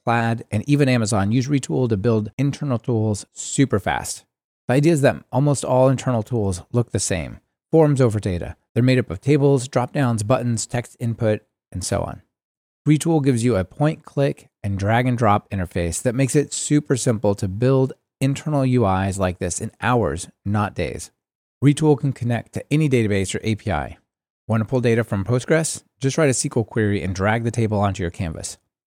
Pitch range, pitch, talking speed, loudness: 105-135 Hz, 120 Hz, 185 wpm, -21 LUFS